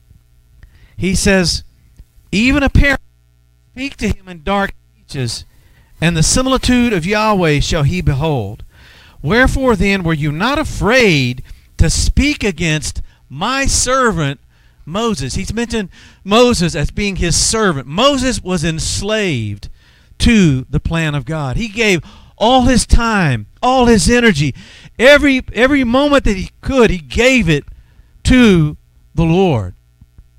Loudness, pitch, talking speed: -14 LUFS, 175 Hz, 130 wpm